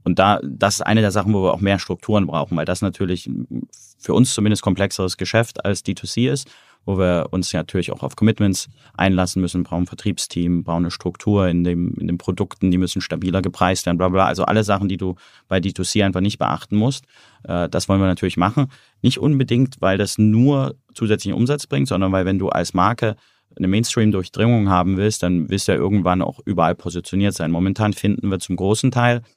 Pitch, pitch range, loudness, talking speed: 95 Hz, 90-105 Hz, -19 LUFS, 205 wpm